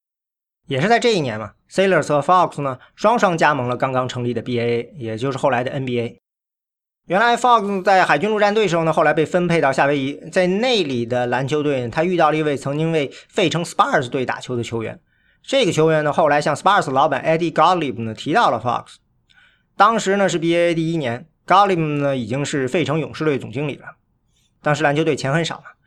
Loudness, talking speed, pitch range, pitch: -18 LUFS, 385 characters per minute, 130-175 Hz, 150 Hz